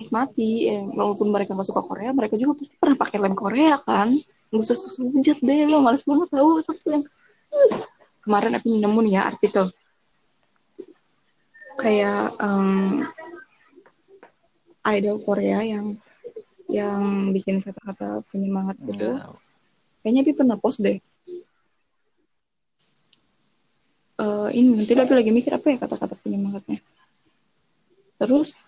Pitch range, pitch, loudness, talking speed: 205-300 Hz, 235 Hz, -22 LUFS, 120 wpm